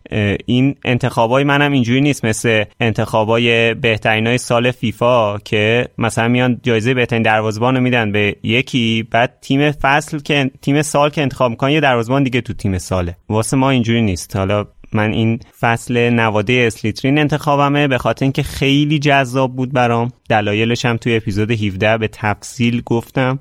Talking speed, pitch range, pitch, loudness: 160 wpm, 110-135 Hz, 120 Hz, -15 LUFS